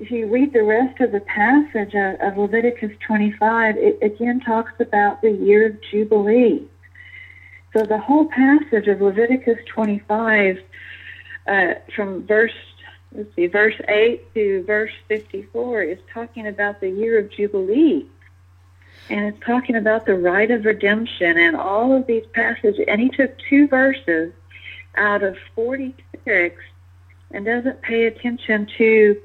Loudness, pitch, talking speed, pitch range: -18 LUFS, 215 Hz, 140 wpm, 195-235 Hz